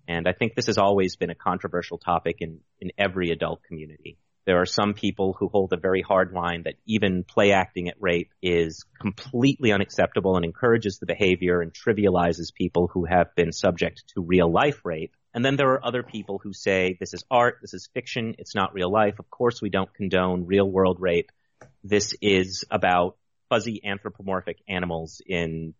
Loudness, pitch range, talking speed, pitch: -24 LUFS, 90-105 Hz, 190 wpm, 95 Hz